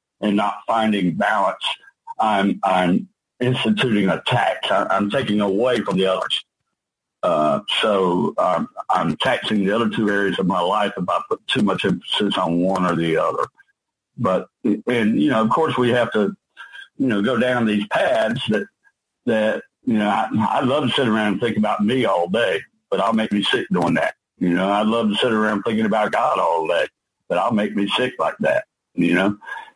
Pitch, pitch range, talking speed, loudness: 105 Hz, 100-125 Hz, 195 wpm, -20 LUFS